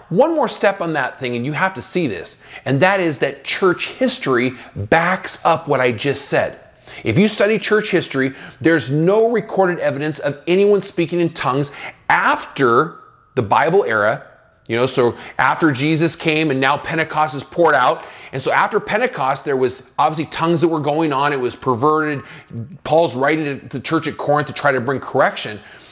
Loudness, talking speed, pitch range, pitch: -18 LUFS, 190 wpm, 140-175 Hz, 155 Hz